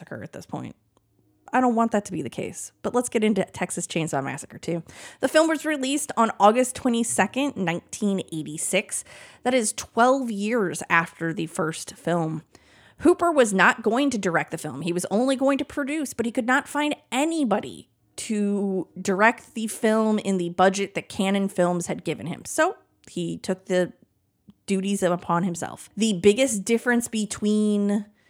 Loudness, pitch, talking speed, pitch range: -24 LUFS, 205 Hz, 170 wpm, 180-245 Hz